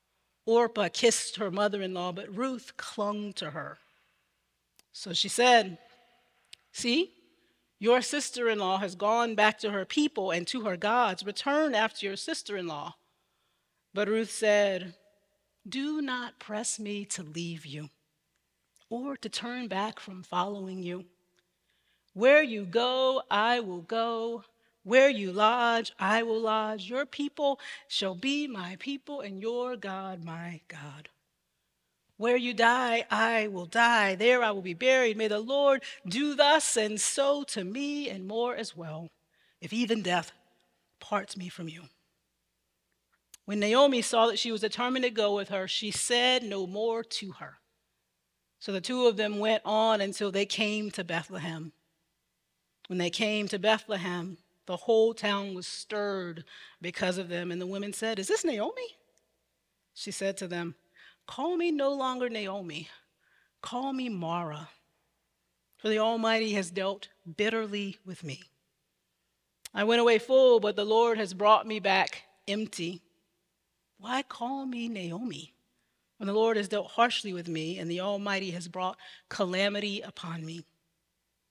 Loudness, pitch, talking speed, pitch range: -29 LUFS, 205 Hz, 150 wpm, 180-235 Hz